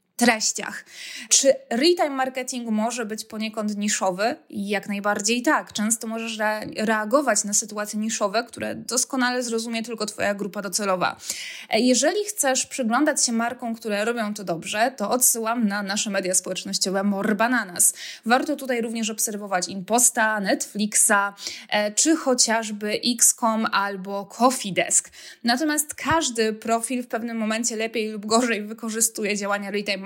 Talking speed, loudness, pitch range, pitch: 130 wpm, -22 LUFS, 210-245 Hz, 225 Hz